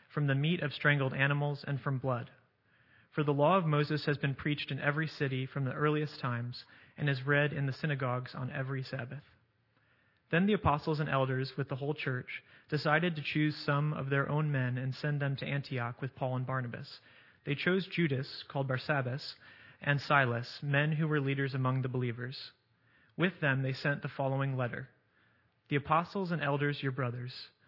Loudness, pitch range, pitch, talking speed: -33 LUFS, 130-150 Hz, 140 Hz, 185 wpm